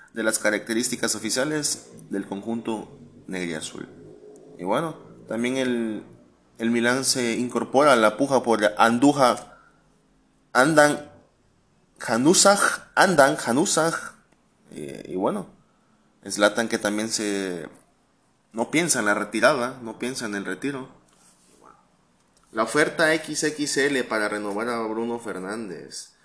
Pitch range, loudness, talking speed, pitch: 105-130 Hz, -23 LUFS, 115 wpm, 115 Hz